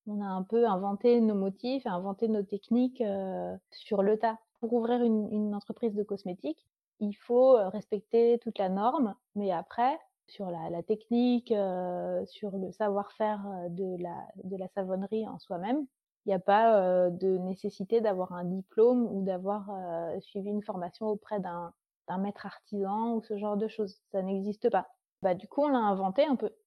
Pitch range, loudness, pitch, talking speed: 190-230 Hz, -31 LUFS, 205 Hz, 180 wpm